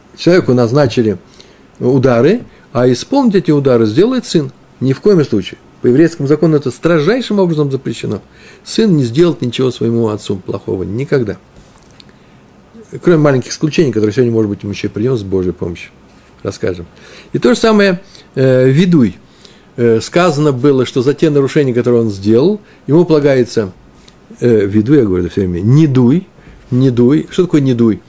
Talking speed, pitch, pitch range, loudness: 160 wpm, 135 Hz, 115-170 Hz, -12 LUFS